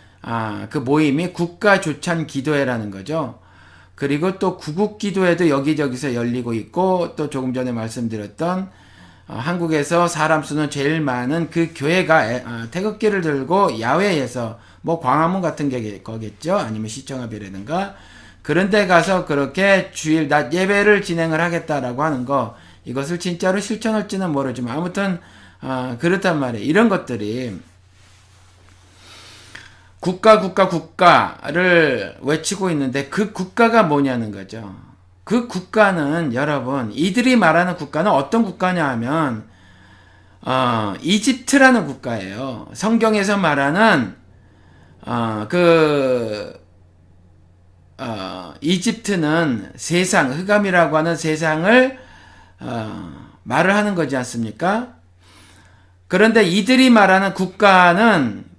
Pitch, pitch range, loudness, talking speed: 150 Hz, 110-185 Hz, -18 LUFS, 265 characters per minute